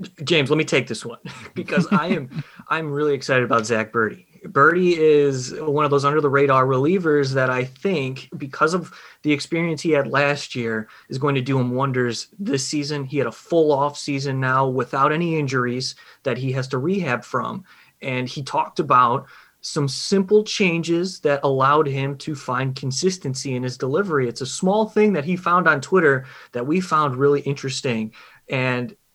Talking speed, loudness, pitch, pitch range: 185 wpm, -21 LUFS, 140 Hz, 130-160 Hz